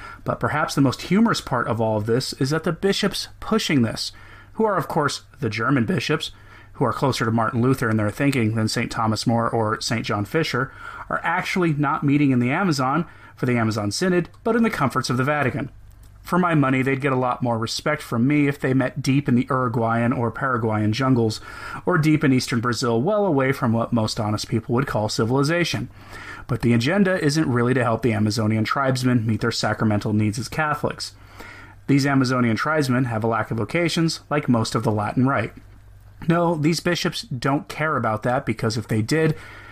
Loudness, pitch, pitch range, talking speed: -22 LUFS, 125 Hz, 110-145 Hz, 205 wpm